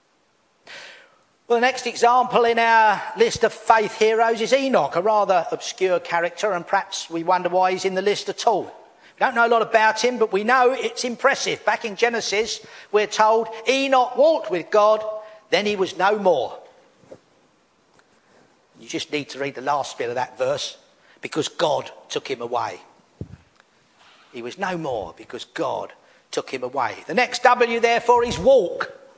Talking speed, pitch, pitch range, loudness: 175 wpm, 225 Hz, 205-245 Hz, -21 LUFS